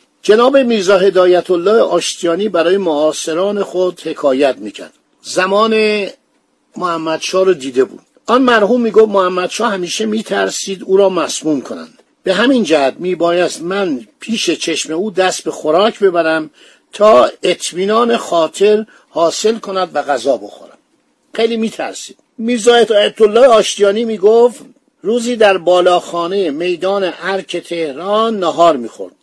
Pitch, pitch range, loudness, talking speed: 195 Hz, 175-225 Hz, -13 LUFS, 125 wpm